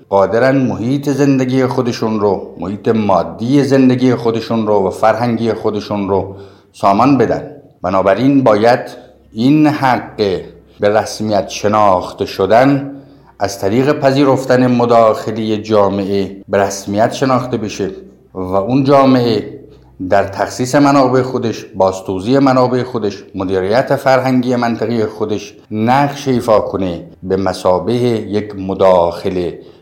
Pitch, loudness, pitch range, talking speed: 110 Hz, -14 LUFS, 100-130 Hz, 110 wpm